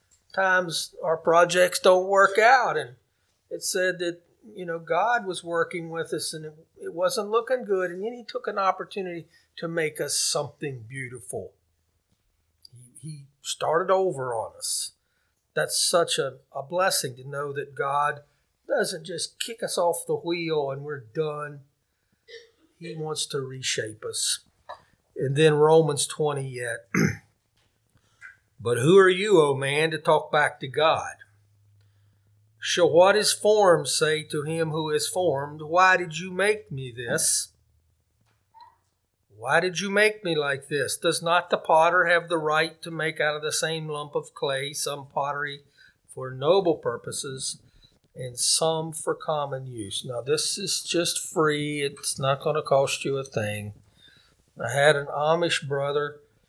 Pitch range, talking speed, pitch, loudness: 135-175 Hz, 155 wpm, 155 Hz, -24 LUFS